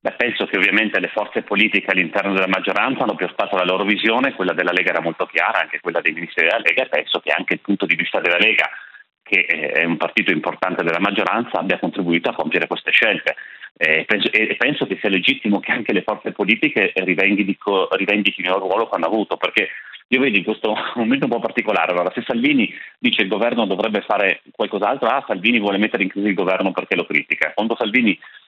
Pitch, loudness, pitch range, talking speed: 100 Hz, -18 LUFS, 95-110 Hz, 215 wpm